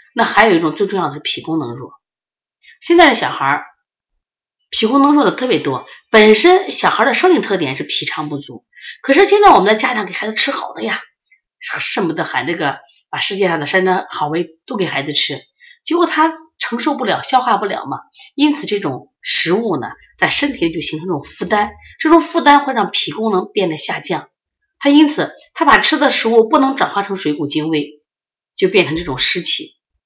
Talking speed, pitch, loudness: 290 characters per minute, 225 Hz, -14 LUFS